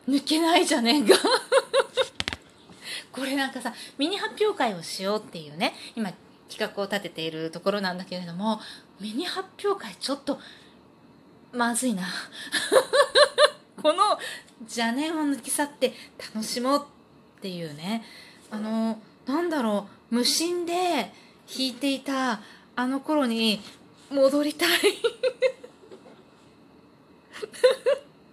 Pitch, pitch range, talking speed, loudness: 265 Hz, 220-335 Hz, 215 characters per minute, -26 LUFS